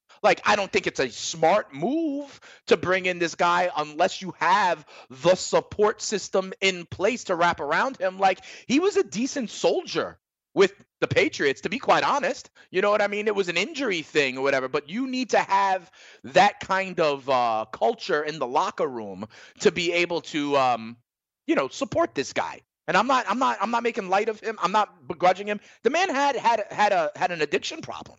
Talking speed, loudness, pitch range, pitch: 210 wpm, -24 LUFS, 175-240 Hz, 195 Hz